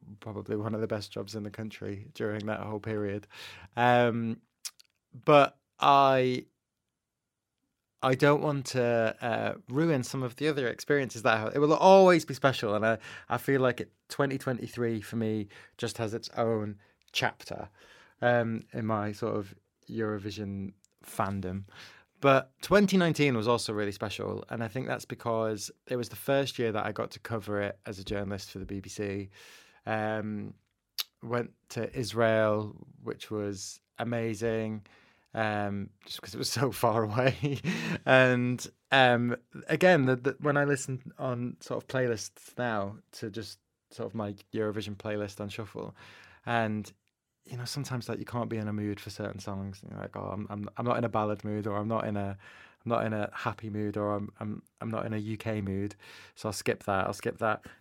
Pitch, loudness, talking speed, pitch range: 110 Hz, -30 LUFS, 180 wpm, 105-125 Hz